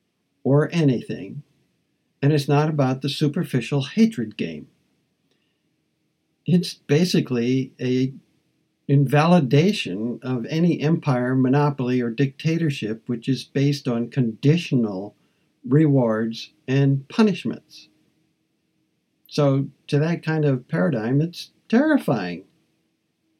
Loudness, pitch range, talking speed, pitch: -22 LUFS, 130-160 Hz, 90 wpm, 145 Hz